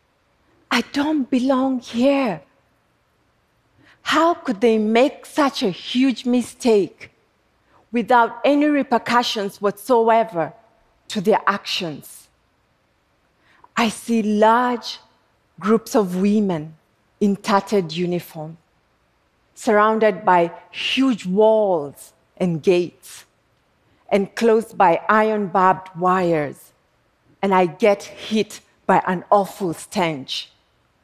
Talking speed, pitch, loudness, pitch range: 95 wpm, 210 Hz, -19 LUFS, 185-240 Hz